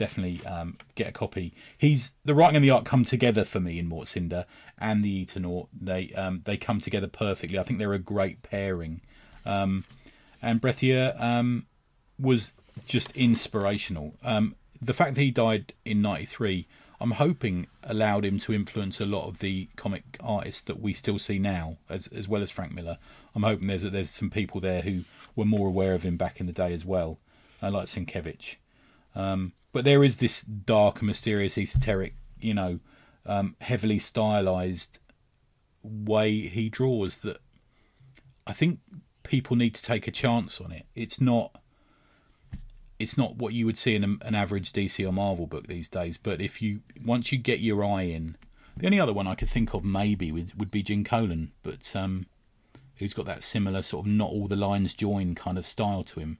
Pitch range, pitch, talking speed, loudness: 95-115 Hz, 105 Hz, 185 wpm, -28 LUFS